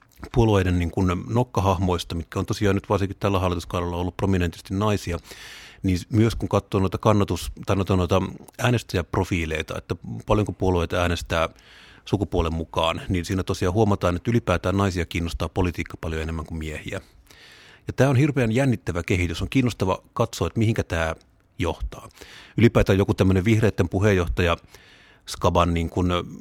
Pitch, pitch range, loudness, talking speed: 95 Hz, 85-105 Hz, -24 LUFS, 140 wpm